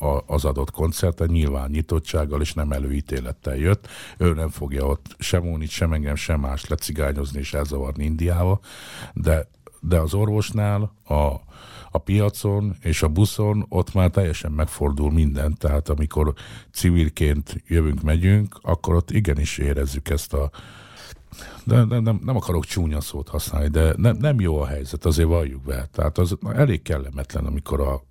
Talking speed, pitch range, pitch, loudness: 155 wpm, 75-95 Hz, 80 Hz, -23 LUFS